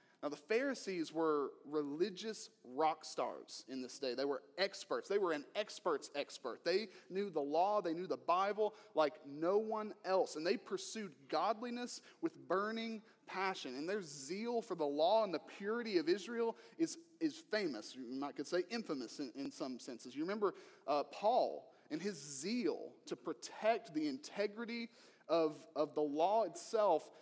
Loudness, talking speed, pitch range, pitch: -40 LUFS, 165 wpm, 155-240 Hz, 210 Hz